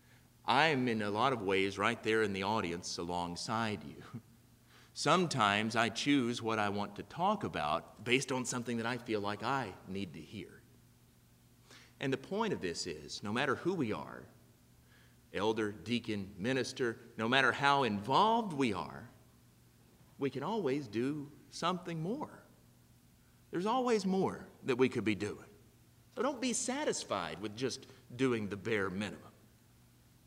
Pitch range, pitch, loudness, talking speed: 105-135 Hz, 115 Hz, -35 LUFS, 155 wpm